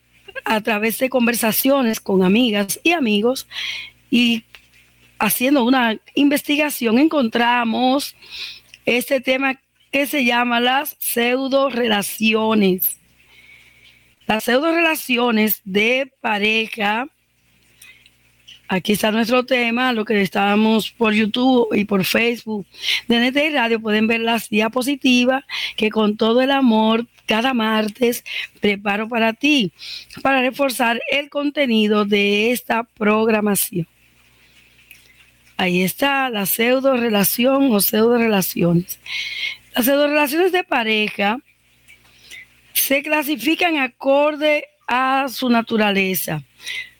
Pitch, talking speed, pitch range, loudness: 235 Hz, 100 wpm, 210-270 Hz, -18 LUFS